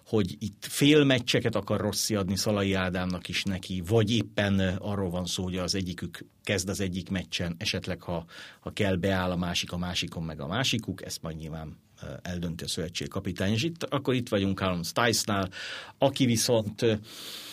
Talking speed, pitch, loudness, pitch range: 170 wpm, 95 Hz, -28 LUFS, 90-110 Hz